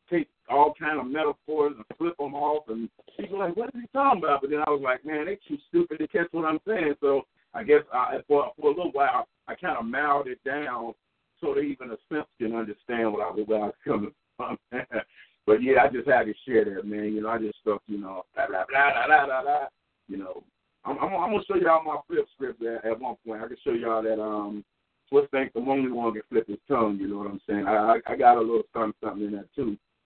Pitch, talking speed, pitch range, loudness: 140 Hz, 250 wpm, 110-165 Hz, -26 LUFS